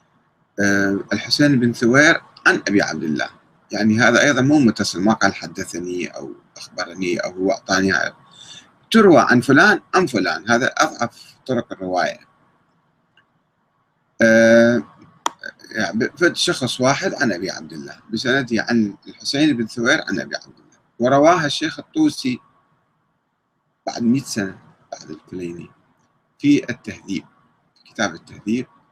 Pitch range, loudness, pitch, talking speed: 100-130 Hz, -18 LUFS, 115 Hz, 125 wpm